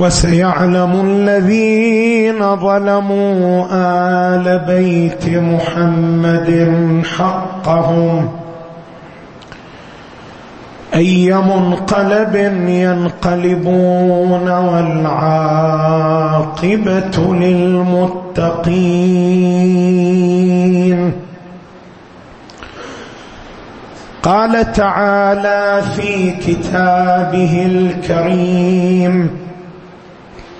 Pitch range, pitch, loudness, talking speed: 170-185 Hz, 180 Hz, -13 LUFS, 35 wpm